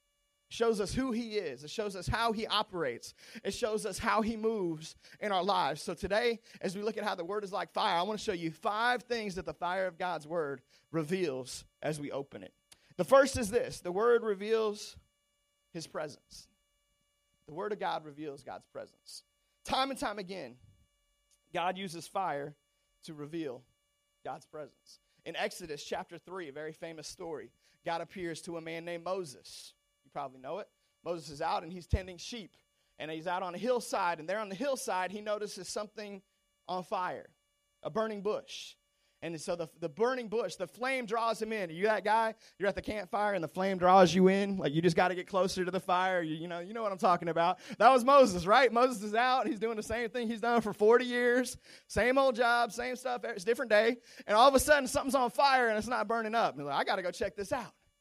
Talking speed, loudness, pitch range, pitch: 220 wpm, -32 LUFS, 170-230 Hz, 195 Hz